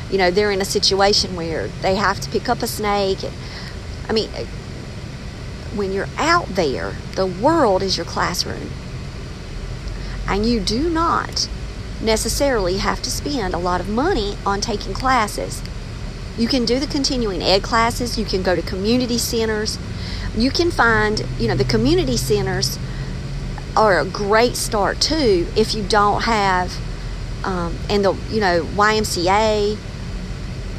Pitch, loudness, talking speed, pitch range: 205 Hz, -19 LUFS, 150 wpm, 185-230 Hz